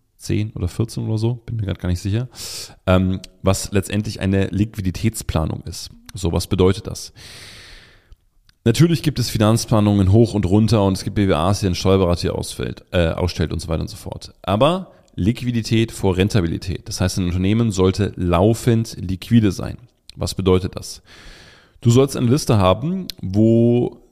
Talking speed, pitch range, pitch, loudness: 160 wpm, 95-115 Hz, 105 Hz, -19 LUFS